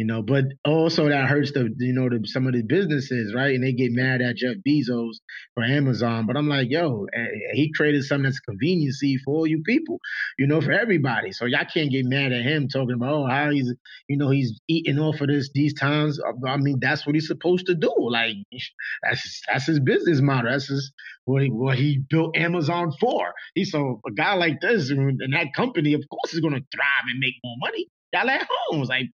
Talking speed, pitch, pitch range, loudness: 220 wpm, 140 Hz, 130-155 Hz, -23 LUFS